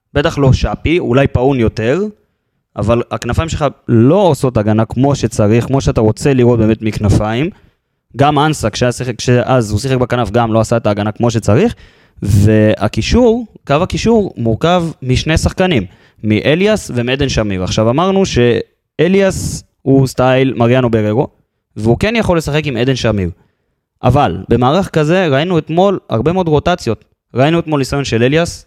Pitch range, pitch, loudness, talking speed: 110-155 Hz, 125 Hz, -13 LUFS, 145 wpm